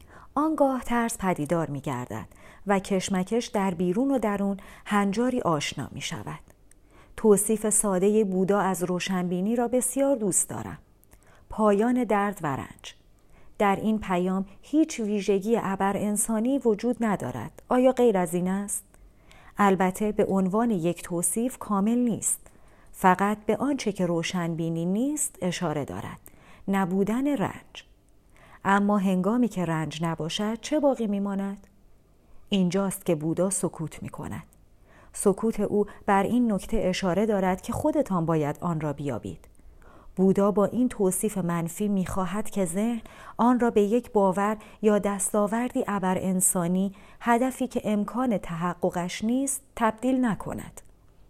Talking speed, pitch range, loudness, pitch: 130 wpm, 175-220 Hz, -26 LUFS, 195 Hz